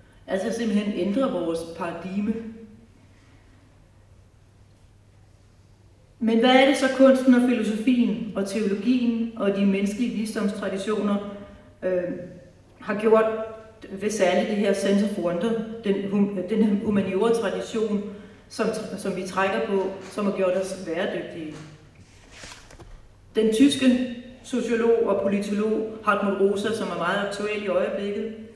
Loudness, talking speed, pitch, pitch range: -24 LUFS, 115 wpm, 200 Hz, 175-220 Hz